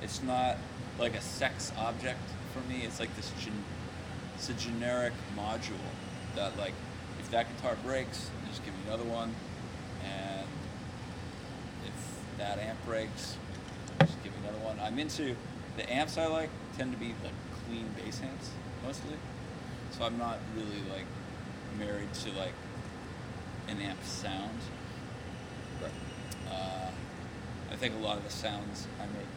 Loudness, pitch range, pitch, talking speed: -38 LUFS, 105-120 Hz, 110 Hz, 150 wpm